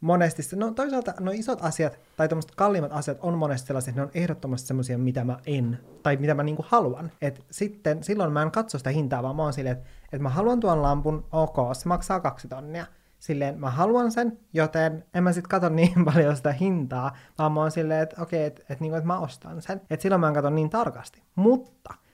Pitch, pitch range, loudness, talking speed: 155 Hz, 140-180 Hz, -26 LUFS, 230 wpm